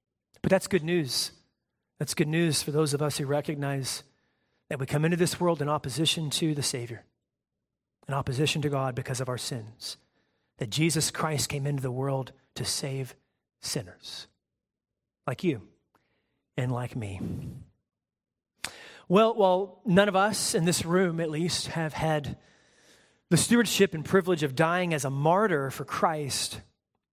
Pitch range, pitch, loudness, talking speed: 135-170 Hz, 150 Hz, -27 LUFS, 155 wpm